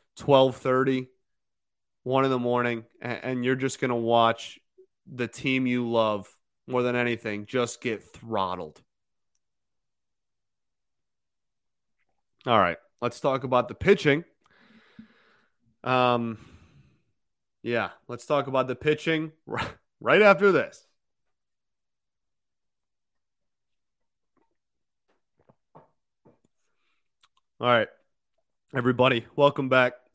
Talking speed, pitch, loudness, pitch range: 85 wpm, 130 Hz, -25 LUFS, 120-145 Hz